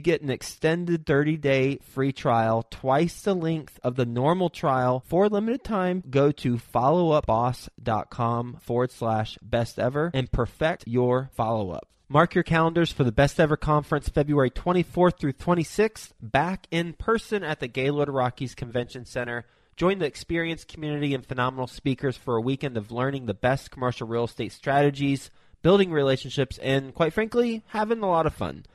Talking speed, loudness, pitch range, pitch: 165 wpm, -25 LUFS, 125-165 Hz, 140 Hz